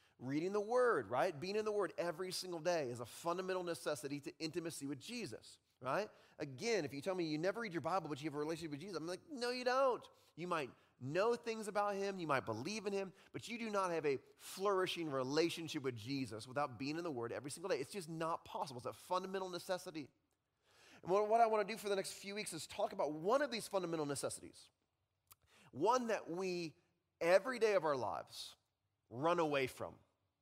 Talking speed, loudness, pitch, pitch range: 215 wpm, -40 LUFS, 175 Hz, 150-205 Hz